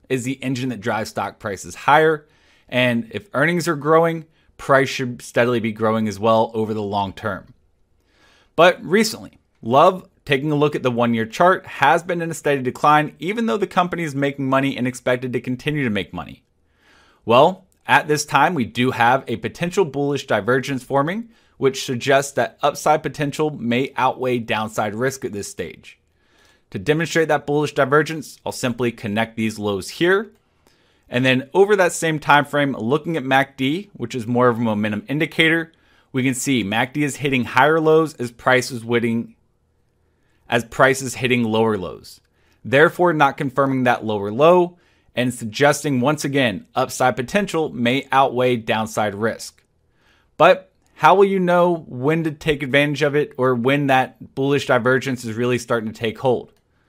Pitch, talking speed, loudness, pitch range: 135 Hz, 170 wpm, -19 LUFS, 120-150 Hz